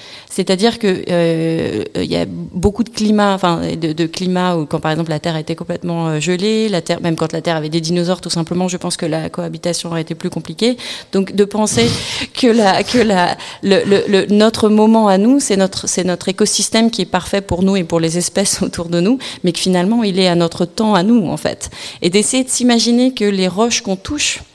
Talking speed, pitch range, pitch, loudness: 230 wpm, 170-210 Hz, 185 Hz, -15 LUFS